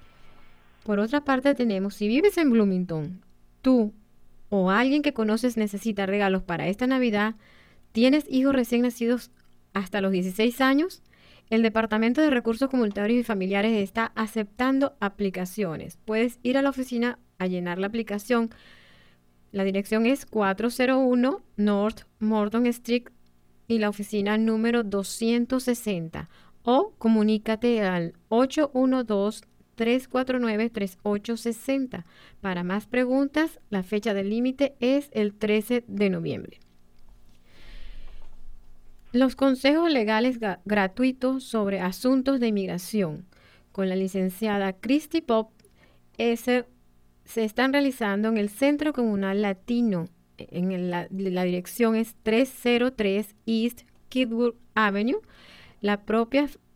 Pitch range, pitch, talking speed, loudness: 195-245 Hz, 220 Hz, 115 wpm, -25 LUFS